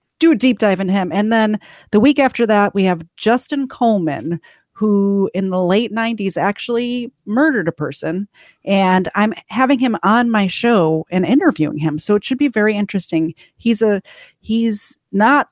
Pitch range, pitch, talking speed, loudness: 190-235 Hz, 210 Hz, 175 wpm, -16 LUFS